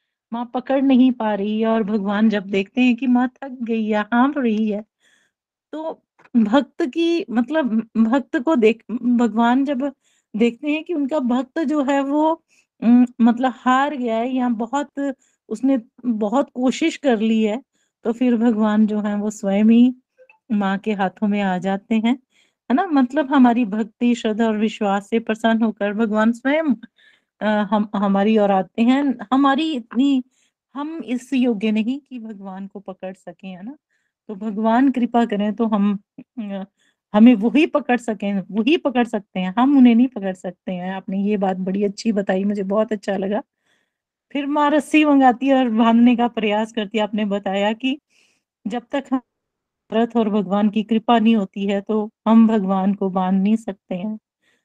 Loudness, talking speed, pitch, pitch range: -19 LUFS, 165 wpm, 230 Hz, 210-260 Hz